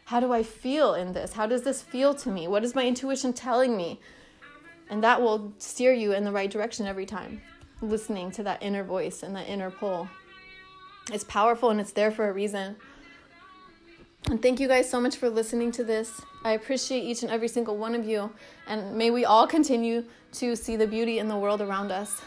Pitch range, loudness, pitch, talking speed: 210-255 Hz, -27 LUFS, 230 Hz, 215 wpm